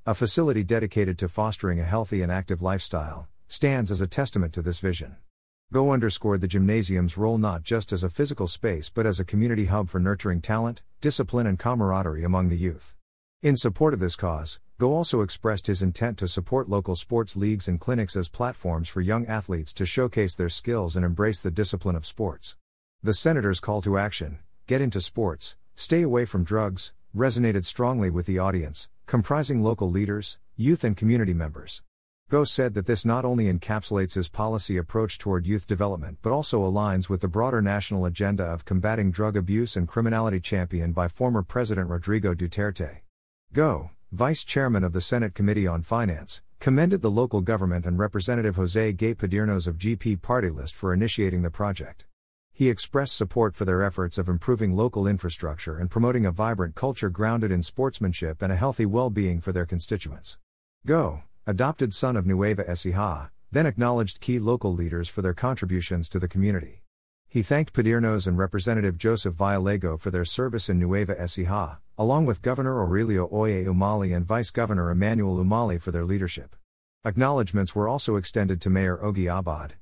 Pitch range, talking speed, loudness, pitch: 90-115 Hz, 175 wpm, -26 LUFS, 100 Hz